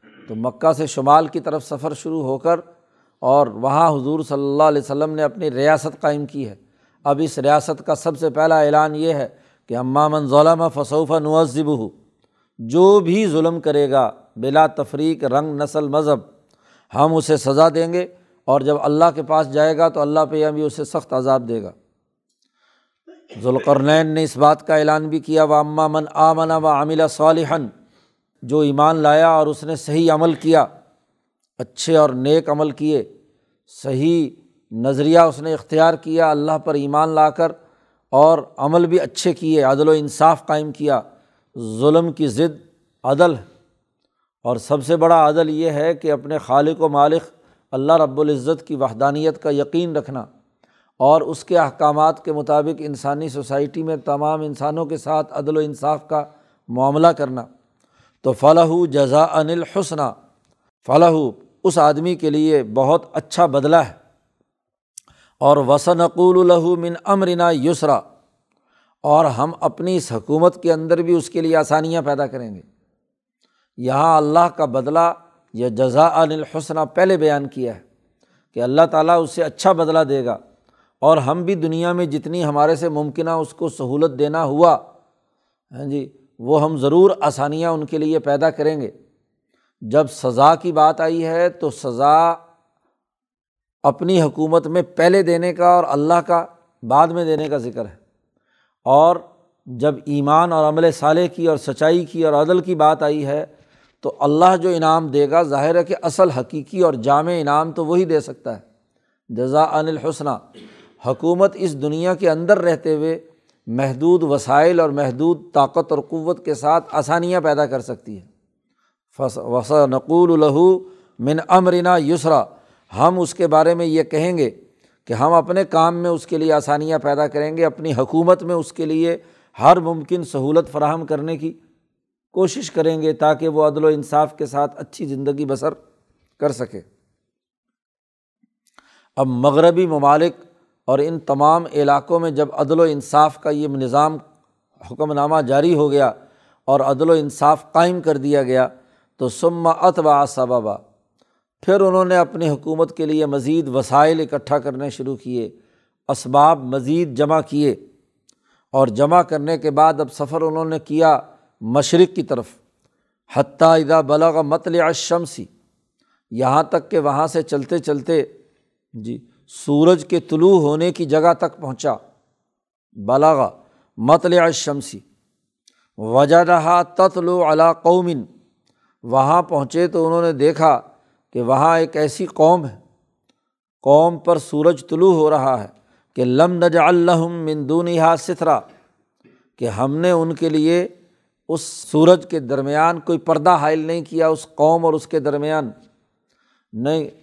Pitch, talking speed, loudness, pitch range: 155 Hz, 155 wpm, -17 LUFS, 145-165 Hz